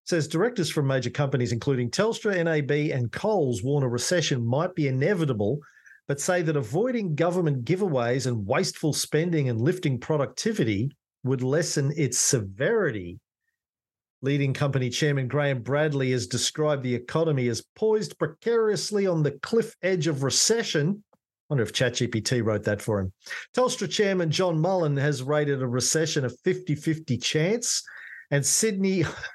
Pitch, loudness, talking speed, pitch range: 150 Hz, -25 LUFS, 145 wpm, 130-180 Hz